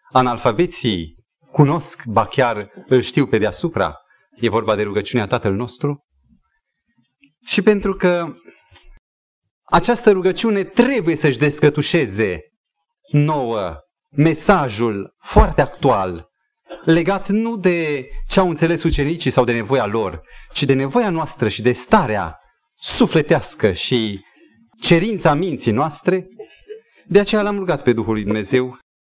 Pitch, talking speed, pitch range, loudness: 145 Hz, 115 wpm, 115-175 Hz, -18 LUFS